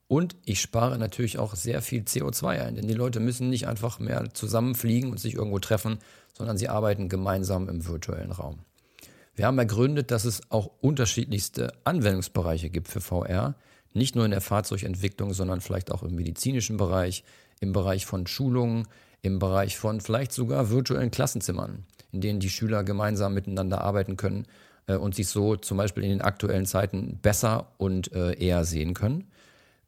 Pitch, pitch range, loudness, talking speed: 105 Hz, 95-115 Hz, -28 LUFS, 165 wpm